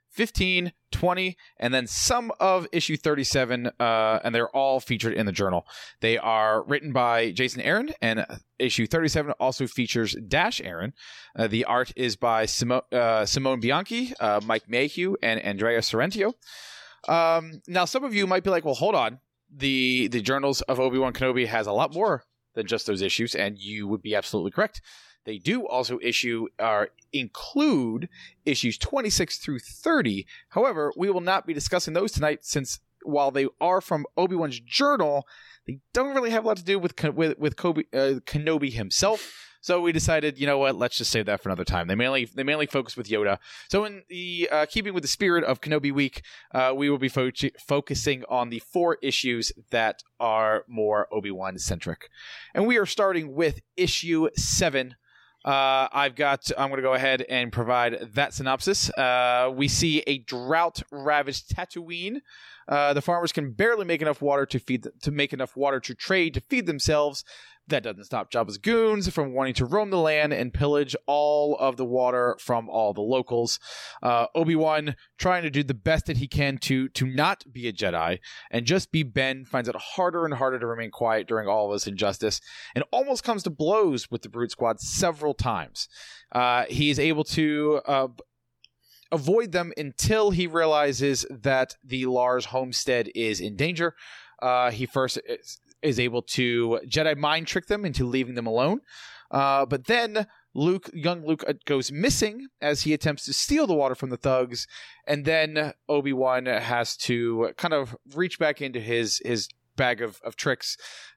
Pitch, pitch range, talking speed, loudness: 140 Hz, 120-160 Hz, 185 wpm, -25 LUFS